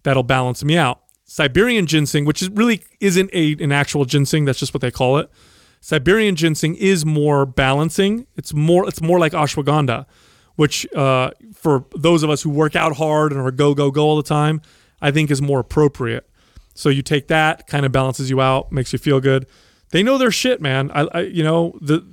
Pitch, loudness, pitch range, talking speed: 150 Hz, -17 LUFS, 140-165 Hz, 210 wpm